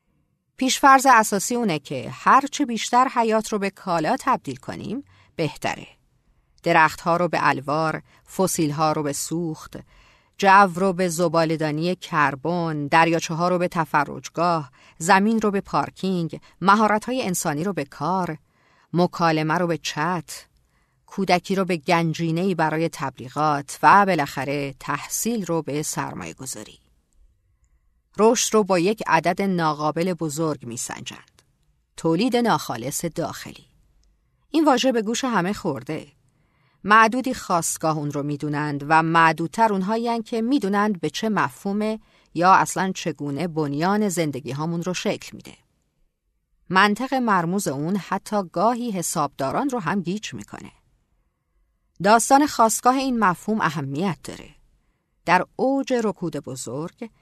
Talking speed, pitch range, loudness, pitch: 125 wpm, 155-205 Hz, -21 LUFS, 170 Hz